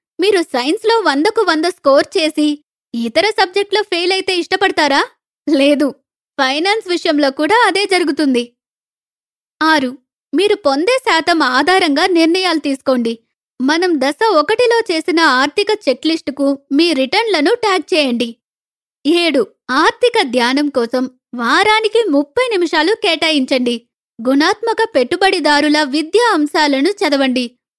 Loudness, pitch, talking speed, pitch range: -14 LUFS, 320 Hz, 100 wpm, 275-385 Hz